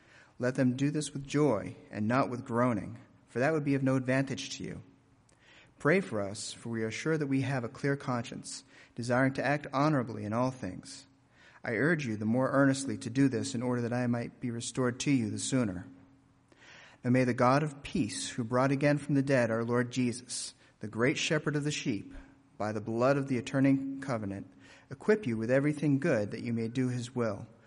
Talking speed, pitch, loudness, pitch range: 215 wpm, 130 Hz, -31 LUFS, 115-140 Hz